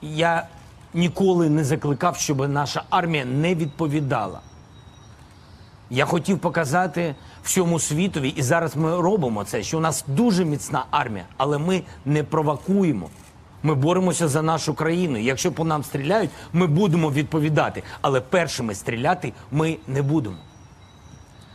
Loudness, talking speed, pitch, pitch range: -22 LUFS, 130 wpm, 155 Hz, 135-170 Hz